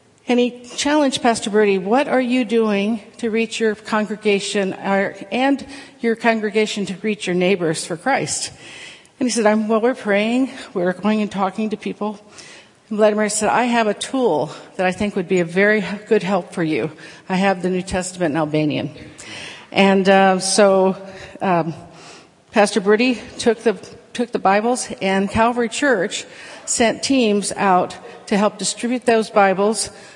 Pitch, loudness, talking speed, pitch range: 210 Hz, -19 LUFS, 160 wpm, 195-230 Hz